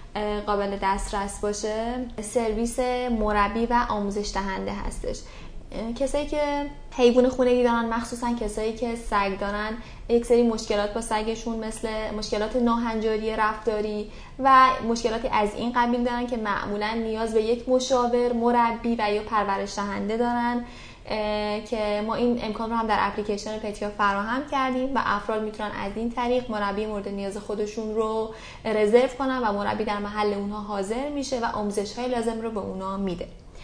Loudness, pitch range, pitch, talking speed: -25 LUFS, 210-240 Hz, 220 Hz, 150 wpm